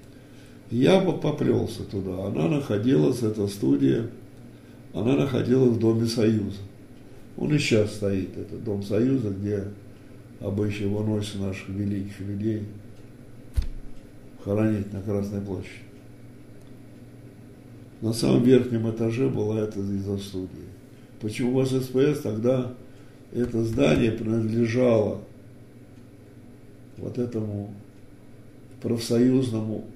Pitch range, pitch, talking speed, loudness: 100-125 Hz, 110 Hz, 95 wpm, -25 LUFS